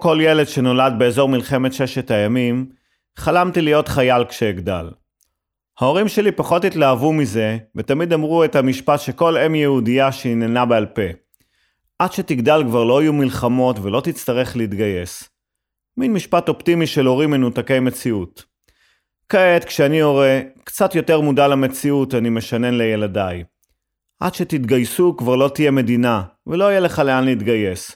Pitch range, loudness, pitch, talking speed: 120-155 Hz, -17 LUFS, 130 Hz, 135 wpm